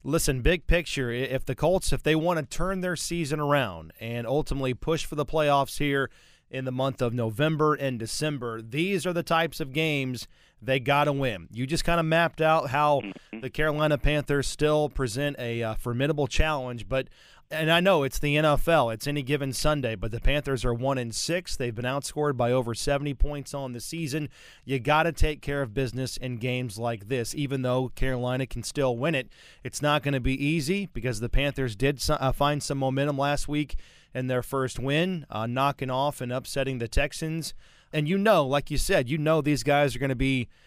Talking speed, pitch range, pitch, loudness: 205 wpm, 130-150 Hz, 140 Hz, -27 LUFS